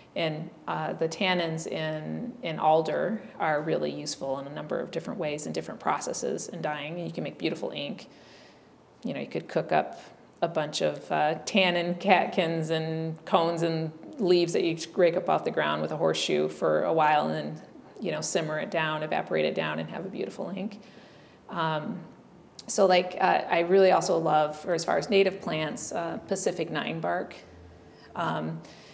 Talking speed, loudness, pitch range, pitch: 185 wpm, -28 LUFS, 150-180 Hz, 165 Hz